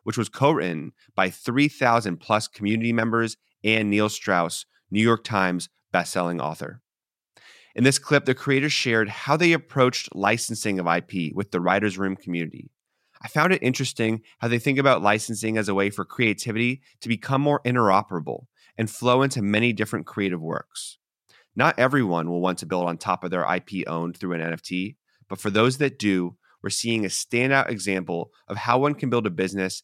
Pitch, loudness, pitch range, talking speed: 110 Hz, -23 LUFS, 95-125 Hz, 185 wpm